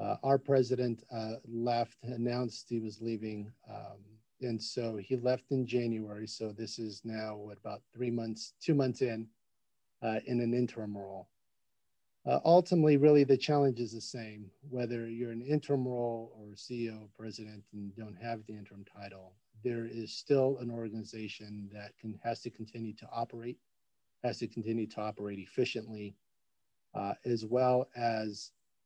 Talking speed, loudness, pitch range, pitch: 160 wpm, -34 LUFS, 110-125 Hz, 115 Hz